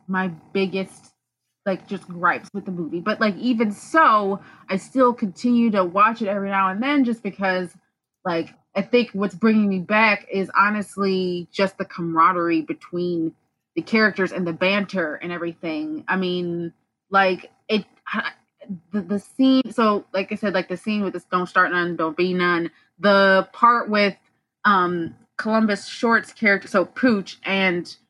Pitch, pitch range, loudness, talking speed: 195 Hz, 180-215 Hz, -21 LUFS, 160 wpm